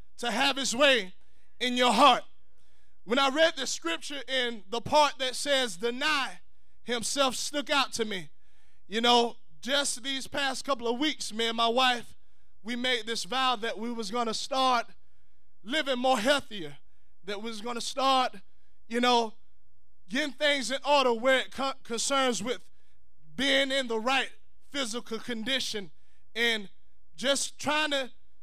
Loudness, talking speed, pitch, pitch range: -28 LUFS, 155 wpm, 250 Hz, 230-275 Hz